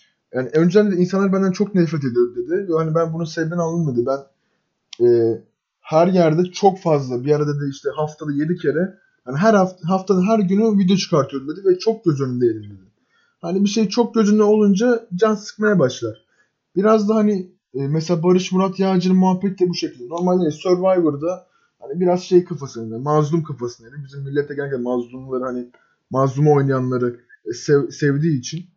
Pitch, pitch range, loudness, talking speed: 170 Hz, 140-190 Hz, -19 LUFS, 170 wpm